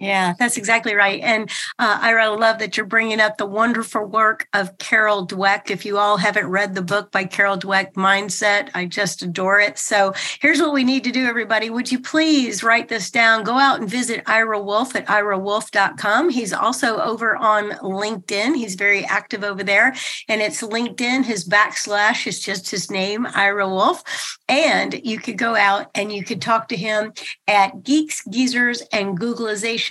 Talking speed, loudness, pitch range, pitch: 185 wpm, -18 LUFS, 200-230 Hz, 215 Hz